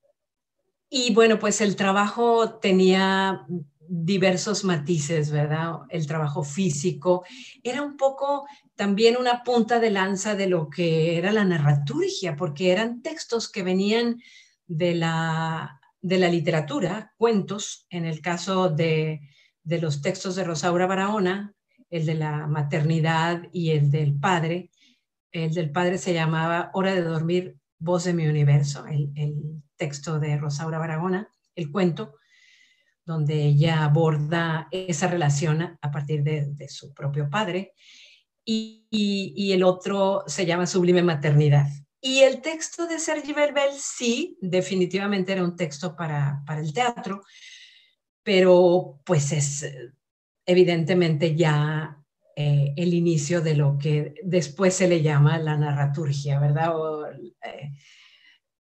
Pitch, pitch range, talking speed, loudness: 175 Hz, 155-200 Hz, 135 wpm, -24 LUFS